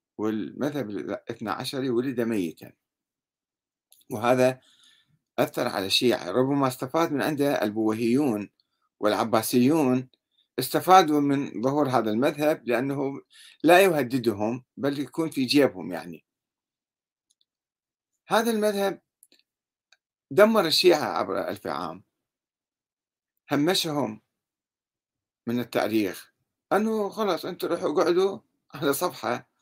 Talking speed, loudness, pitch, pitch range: 90 wpm, -25 LUFS, 135 Hz, 120-165 Hz